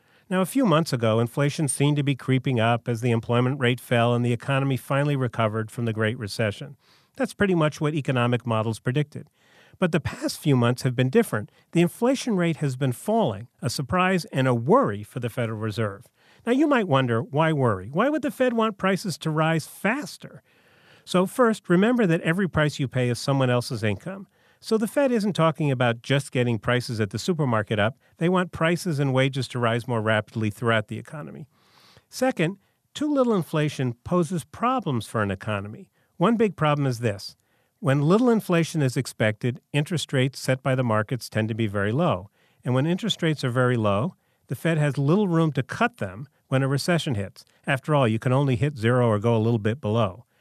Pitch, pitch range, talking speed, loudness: 135 Hz, 120-170 Hz, 200 wpm, -24 LUFS